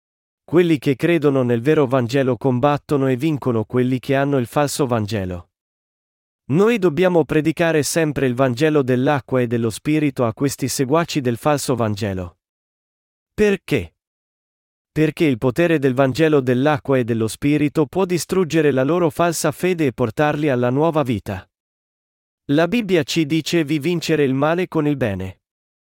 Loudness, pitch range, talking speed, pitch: -19 LUFS, 125-160 Hz, 150 wpm, 145 Hz